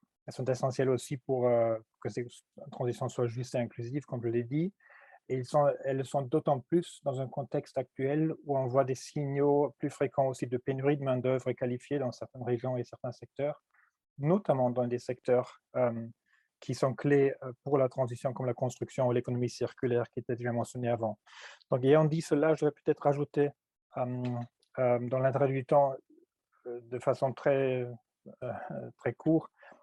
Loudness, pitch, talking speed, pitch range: -32 LUFS, 130 Hz, 180 wpm, 125-145 Hz